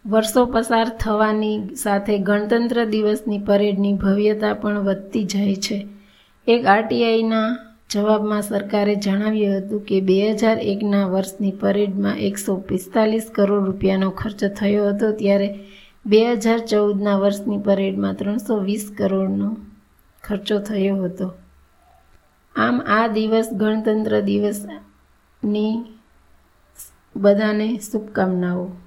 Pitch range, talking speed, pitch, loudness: 195-215 Hz, 105 wpm, 205 Hz, -20 LUFS